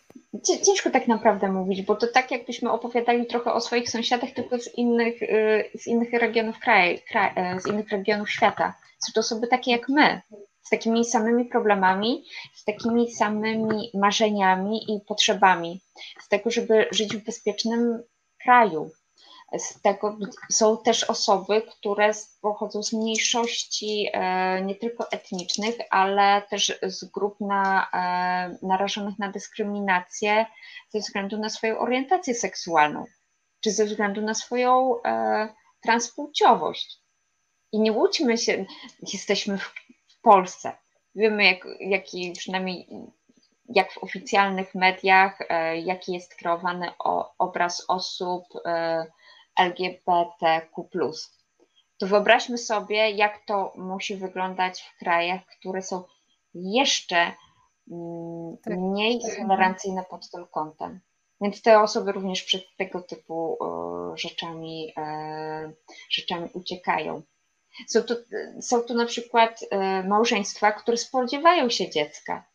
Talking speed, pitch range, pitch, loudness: 120 wpm, 185-230 Hz, 210 Hz, -24 LUFS